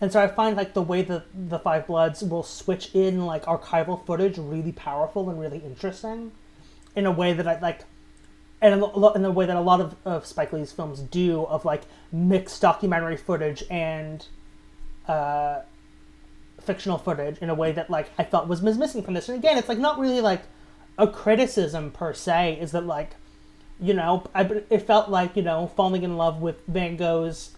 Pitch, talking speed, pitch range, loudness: 175 Hz, 200 wpm, 165-200 Hz, -24 LUFS